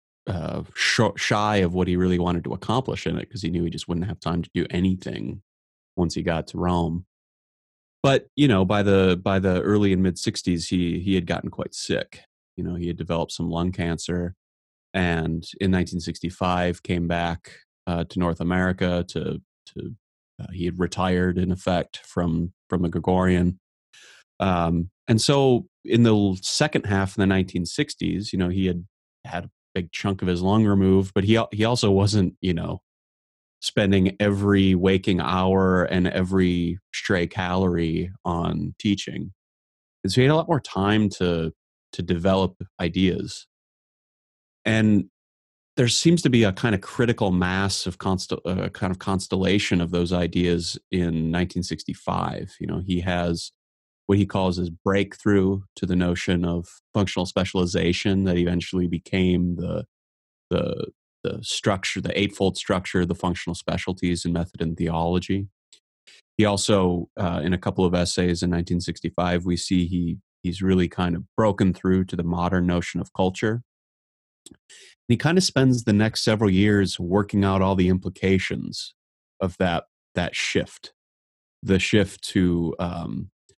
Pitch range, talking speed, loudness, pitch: 85-95 Hz, 160 wpm, -23 LUFS, 90 Hz